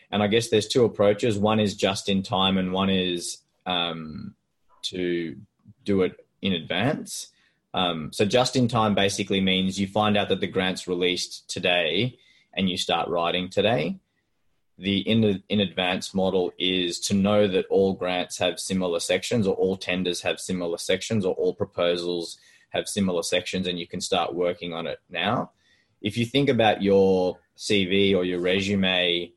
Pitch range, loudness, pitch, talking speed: 90-105 Hz, -24 LUFS, 95 Hz, 170 wpm